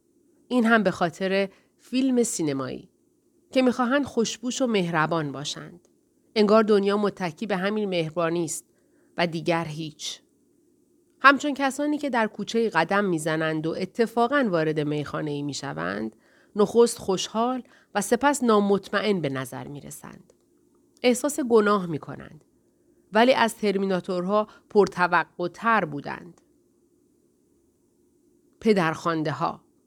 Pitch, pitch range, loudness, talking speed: 210 Hz, 170-265 Hz, -24 LUFS, 105 wpm